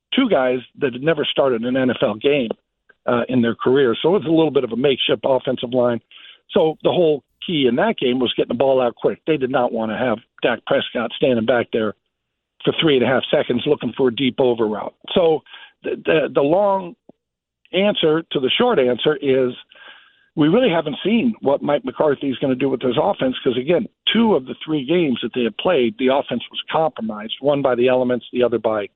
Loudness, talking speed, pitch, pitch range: -19 LUFS, 220 wpm, 135 Hz, 125-160 Hz